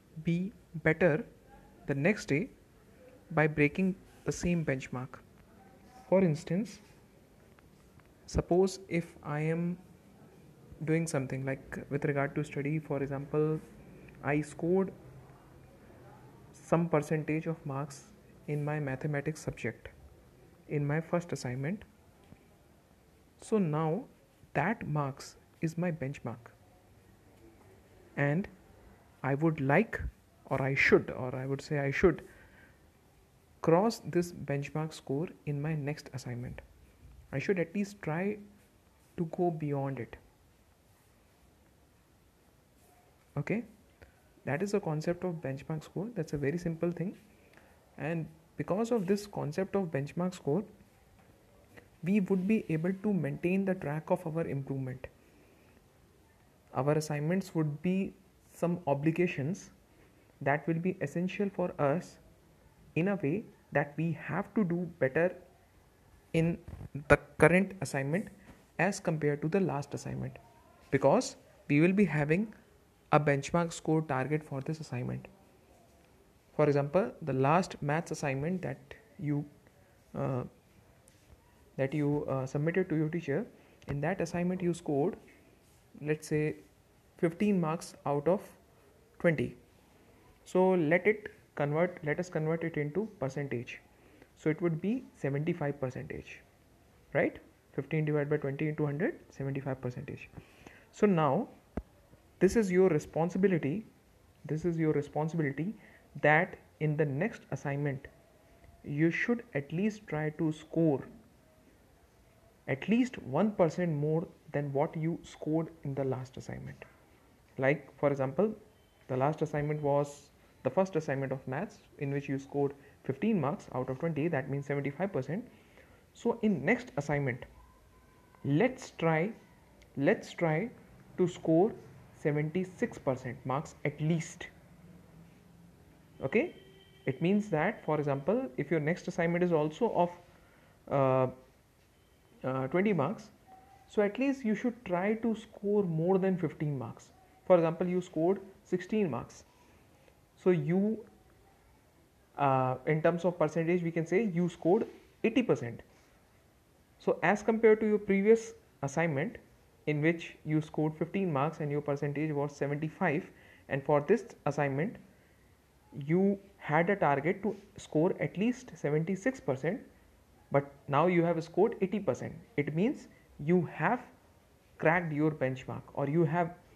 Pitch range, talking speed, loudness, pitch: 140-180 Hz, 130 wpm, -32 LUFS, 155 Hz